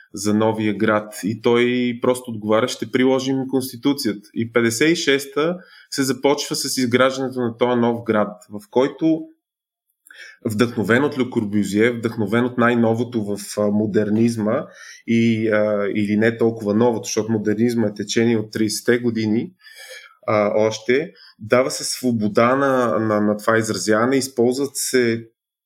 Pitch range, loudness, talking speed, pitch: 110-125 Hz, -20 LUFS, 130 wpm, 115 Hz